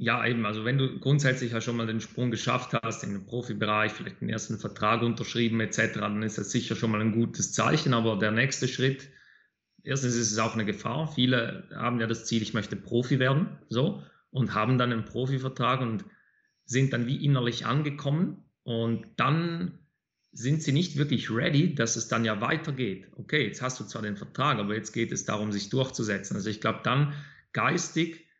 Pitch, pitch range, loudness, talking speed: 120 Hz, 110-135 Hz, -28 LUFS, 195 wpm